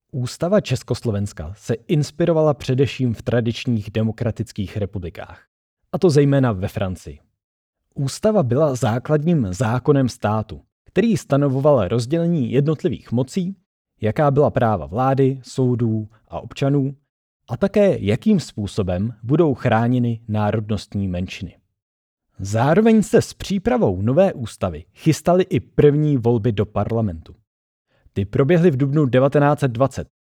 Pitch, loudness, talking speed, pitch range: 125 Hz, -19 LUFS, 110 wpm, 105-150 Hz